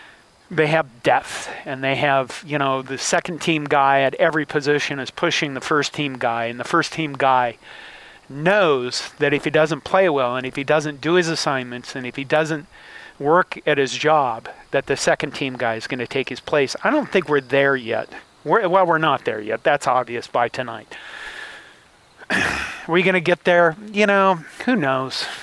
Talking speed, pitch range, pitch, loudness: 200 wpm, 135-175 Hz, 150 Hz, -20 LUFS